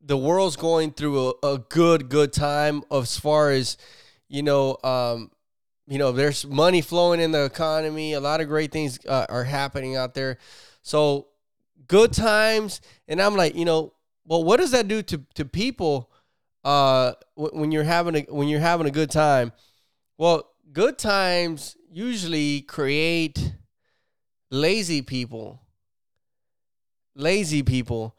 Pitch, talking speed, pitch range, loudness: 150 Hz, 150 wpm, 135-165 Hz, -23 LUFS